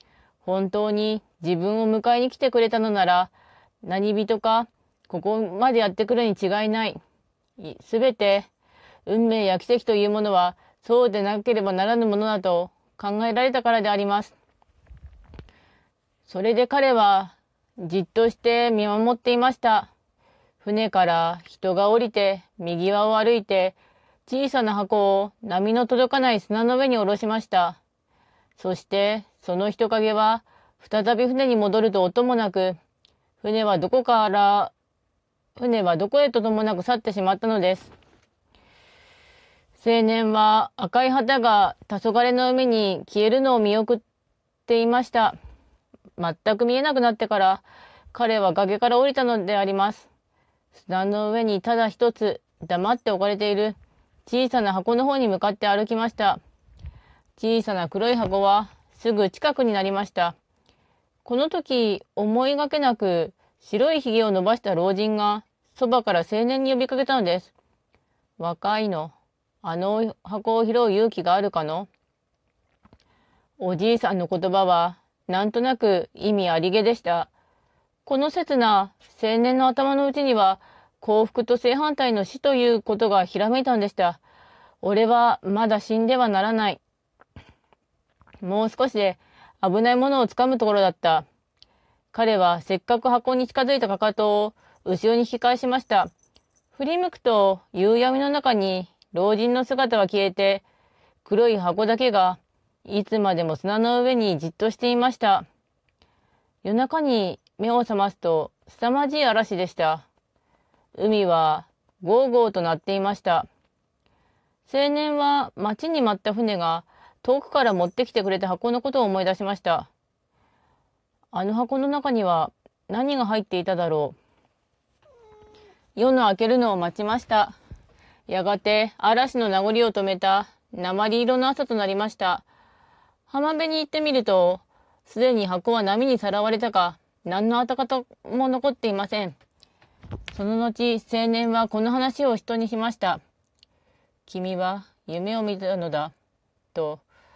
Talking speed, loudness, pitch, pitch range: 270 characters per minute, -22 LUFS, 215 Hz, 195-245 Hz